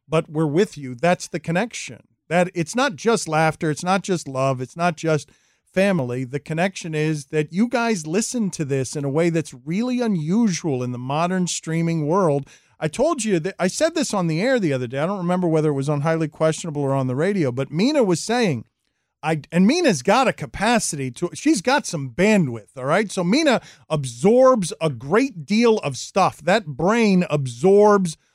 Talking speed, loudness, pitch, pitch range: 200 wpm, -21 LUFS, 170 Hz, 150-210 Hz